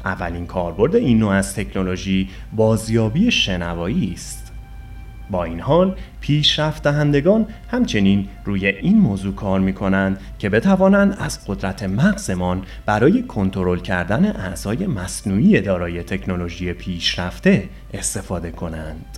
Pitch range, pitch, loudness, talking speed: 90-140 Hz, 95 Hz, -19 LUFS, 110 wpm